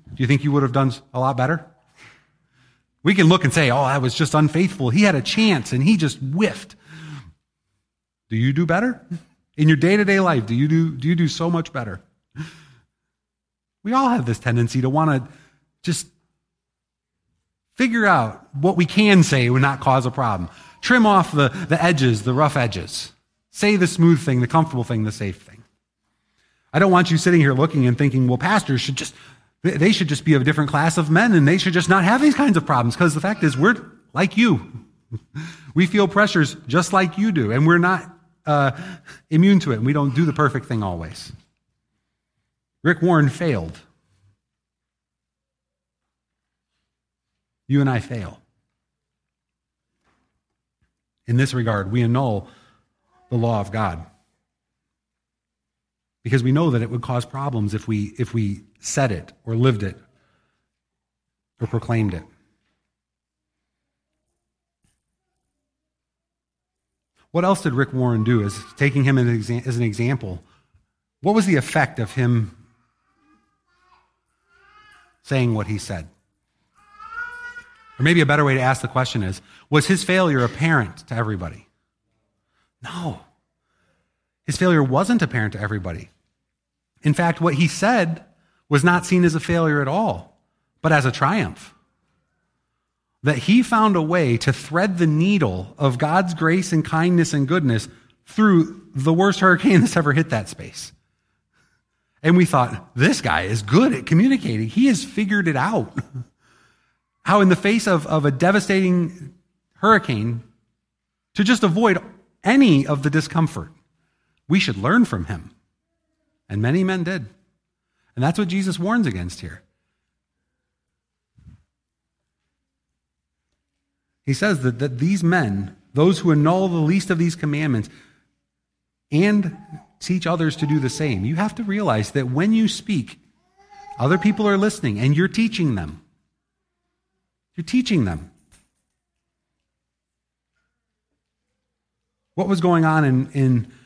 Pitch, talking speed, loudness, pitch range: 145 Hz, 150 wpm, -19 LUFS, 115-180 Hz